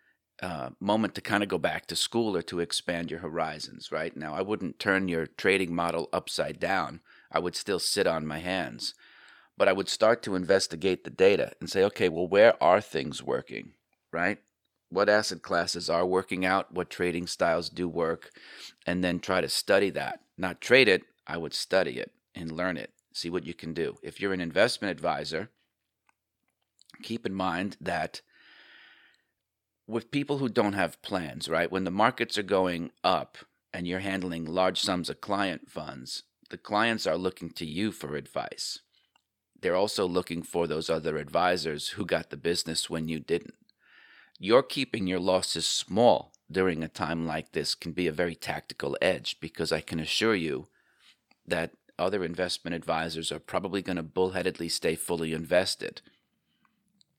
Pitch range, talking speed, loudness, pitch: 85-100 Hz, 175 wpm, -29 LUFS, 90 Hz